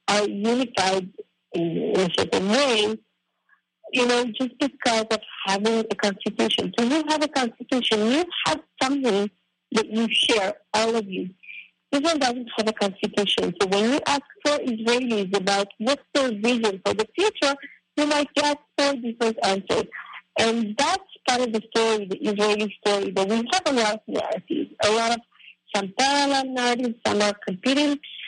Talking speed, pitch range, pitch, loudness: 165 wpm, 205-270 Hz, 230 Hz, -23 LUFS